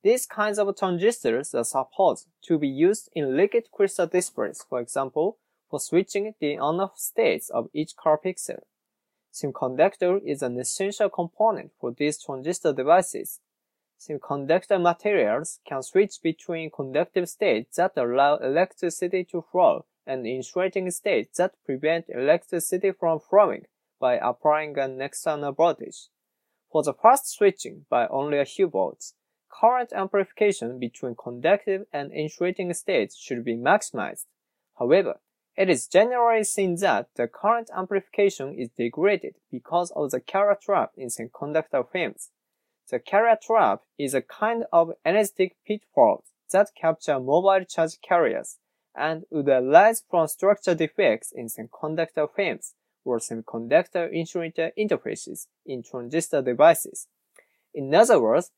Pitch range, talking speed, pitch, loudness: 150-200 Hz, 130 wpm, 175 Hz, -24 LUFS